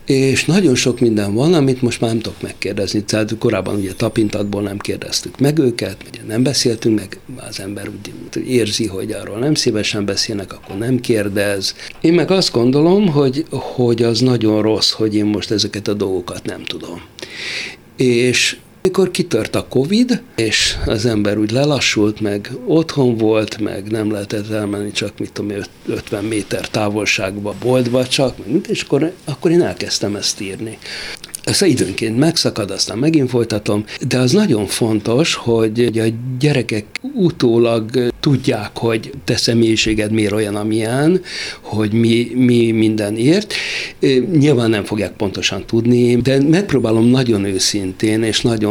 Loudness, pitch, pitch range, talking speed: -16 LUFS, 115 Hz, 105-130 Hz, 150 wpm